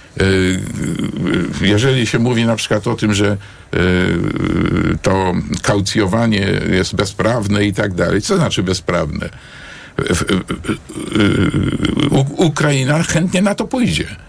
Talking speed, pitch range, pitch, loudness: 95 wpm, 95-135 Hz, 105 Hz, -16 LUFS